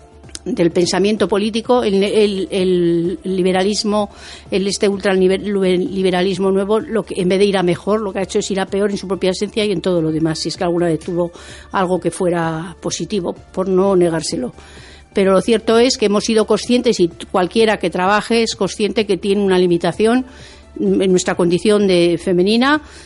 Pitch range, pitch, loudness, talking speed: 180-210 Hz, 195 Hz, -16 LUFS, 185 wpm